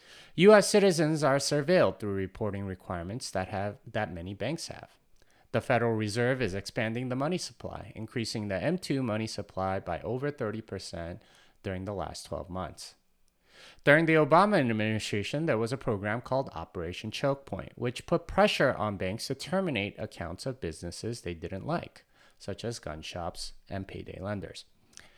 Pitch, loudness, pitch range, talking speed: 110 Hz, -30 LUFS, 95-135 Hz, 155 wpm